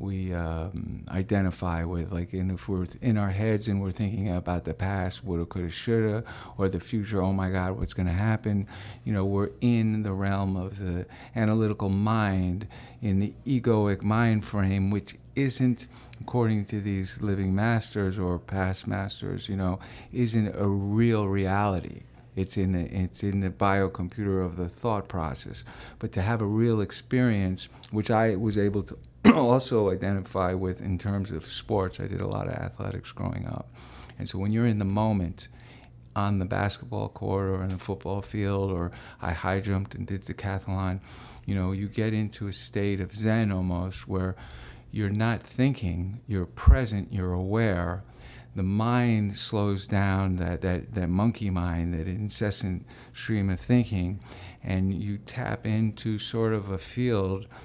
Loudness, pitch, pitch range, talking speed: -28 LUFS, 100 Hz, 95-110 Hz, 165 wpm